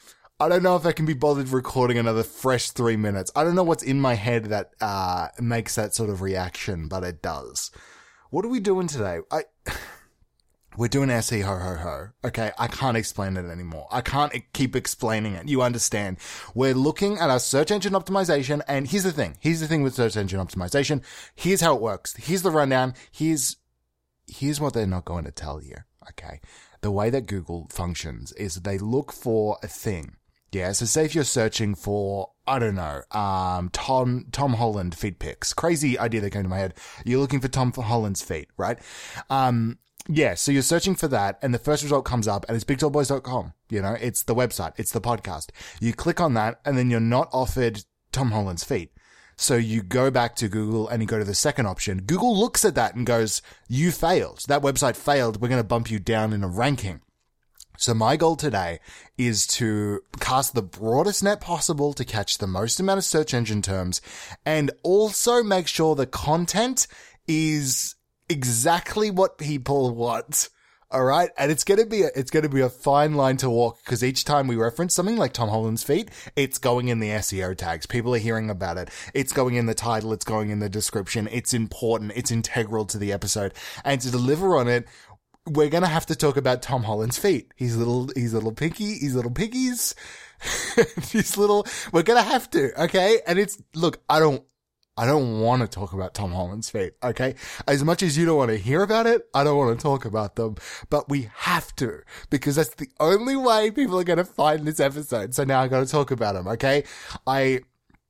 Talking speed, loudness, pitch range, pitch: 210 wpm, -24 LUFS, 110-150 Hz, 125 Hz